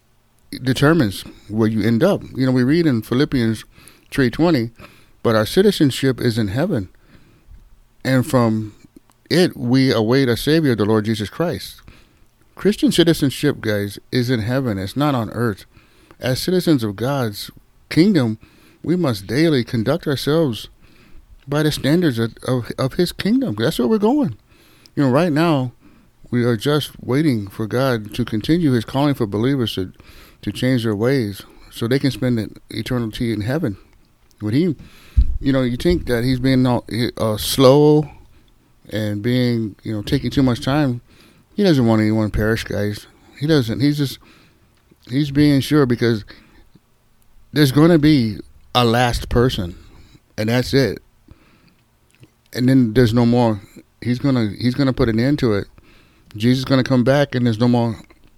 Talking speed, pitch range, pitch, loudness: 160 wpm, 110-140 Hz, 125 Hz, -18 LUFS